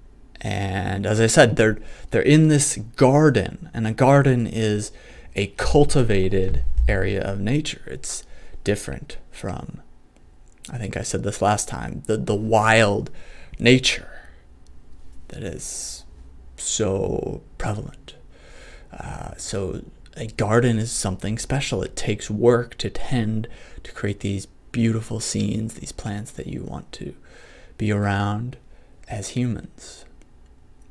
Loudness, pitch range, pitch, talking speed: -22 LUFS, 95-120 Hz, 105 Hz, 120 wpm